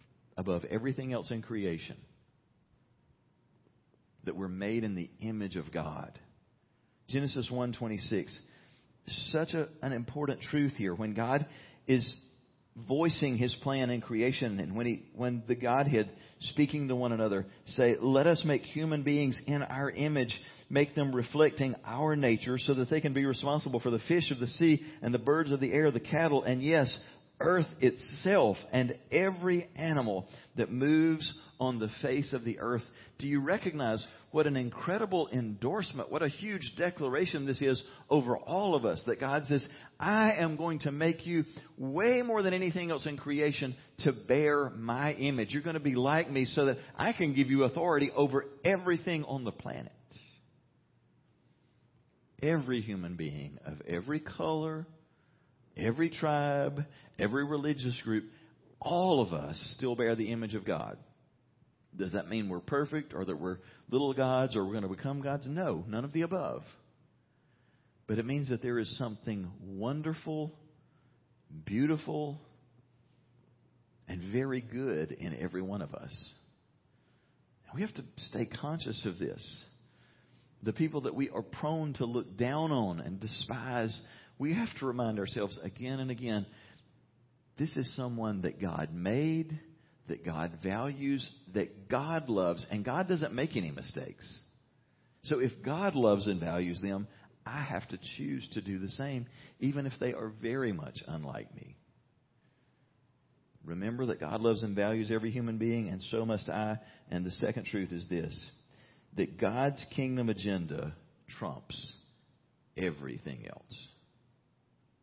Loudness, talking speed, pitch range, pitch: -33 LUFS, 155 wpm, 110-145 Hz, 130 Hz